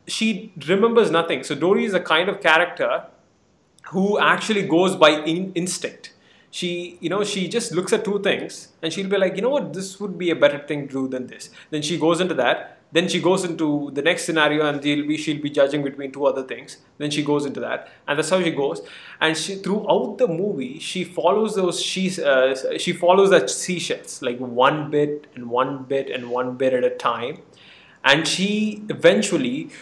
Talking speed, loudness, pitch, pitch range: 205 wpm, -21 LUFS, 170 Hz, 145-190 Hz